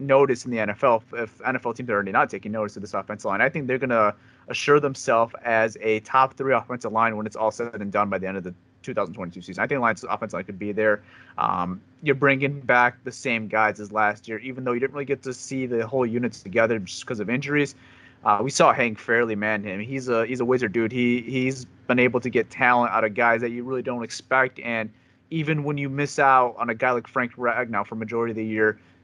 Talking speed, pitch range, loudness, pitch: 250 wpm, 110-130 Hz, -24 LUFS, 120 Hz